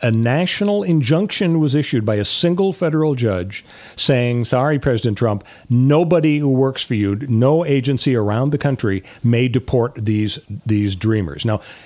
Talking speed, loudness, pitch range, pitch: 150 wpm, -17 LUFS, 110-150 Hz, 125 Hz